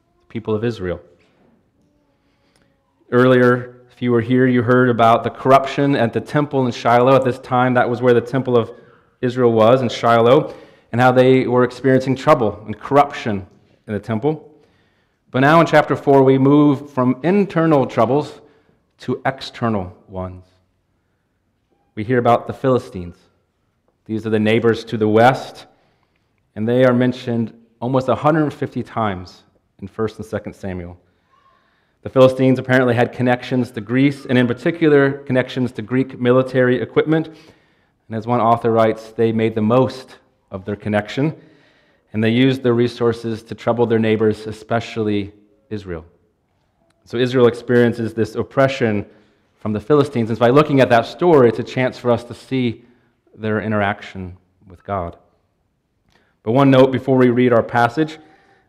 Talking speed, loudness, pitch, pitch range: 155 wpm, -17 LUFS, 120 Hz, 110-130 Hz